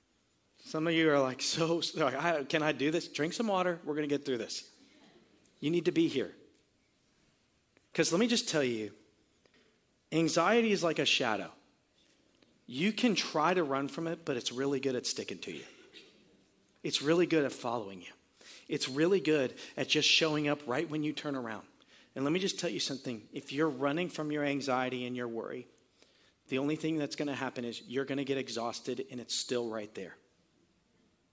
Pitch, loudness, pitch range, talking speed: 150 Hz, -32 LUFS, 135-165 Hz, 200 wpm